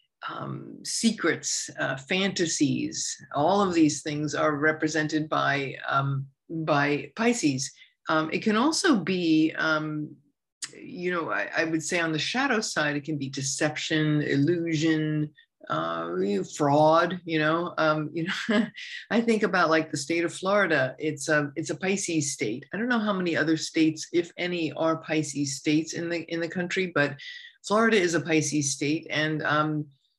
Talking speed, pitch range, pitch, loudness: 160 wpm, 150-180 Hz, 160 Hz, -26 LUFS